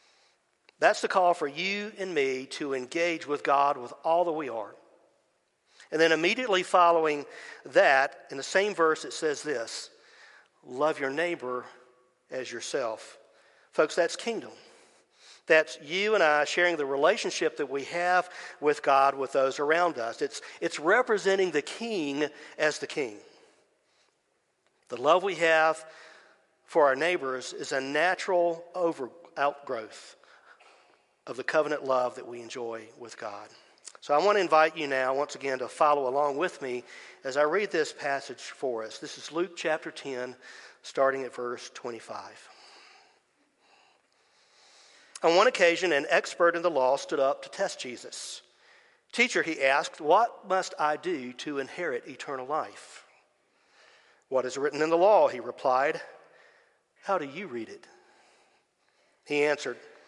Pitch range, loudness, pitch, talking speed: 140-190 Hz, -27 LUFS, 160 Hz, 150 wpm